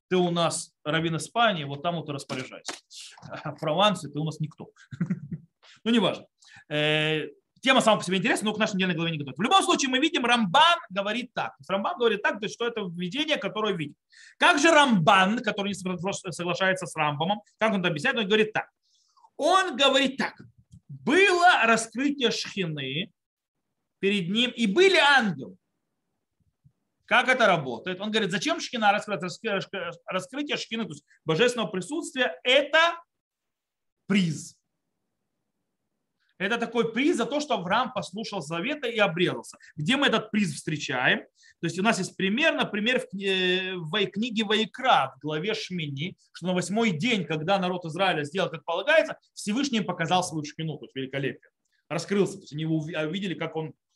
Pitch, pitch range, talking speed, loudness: 200 Hz, 165-235 Hz, 160 wpm, -25 LUFS